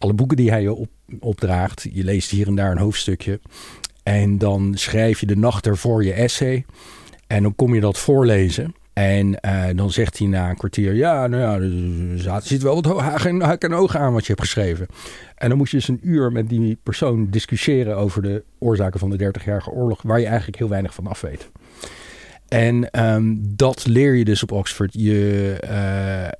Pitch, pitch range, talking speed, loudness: 105 Hz, 100-120 Hz, 205 wpm, -19 LUFS